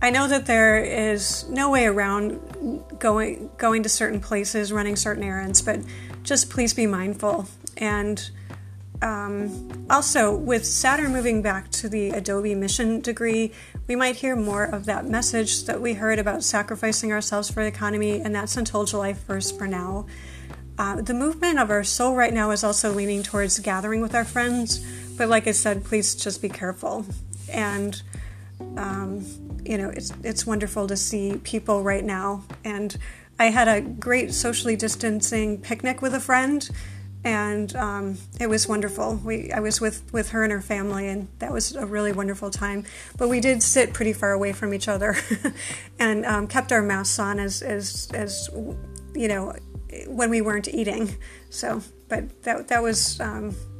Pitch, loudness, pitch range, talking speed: 210 Hz, -24 LUFS, 150-225 Hz, 175 wpm